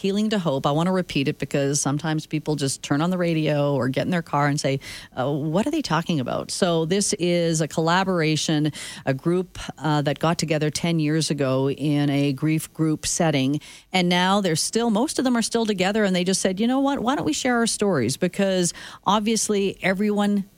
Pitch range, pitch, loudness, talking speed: 145-195 Hz, 165 Hz, -22 LUFS, 215 wpm